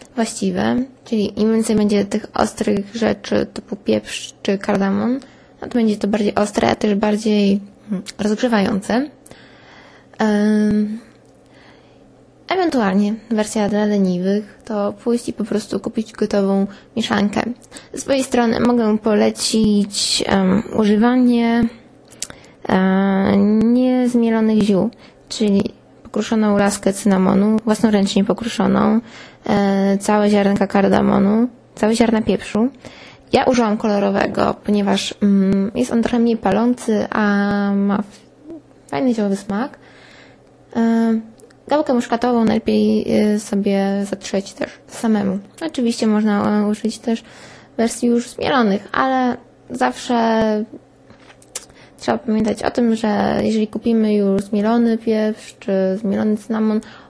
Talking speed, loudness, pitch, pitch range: 105 wpm, -18 LUFS, 215 Hz, 205-230 Hz